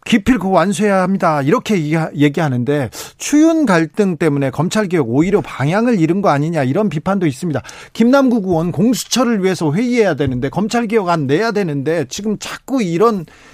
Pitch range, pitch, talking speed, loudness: 155-225 Hz, 185 Hz, 375 characters per minute, -15 LUFS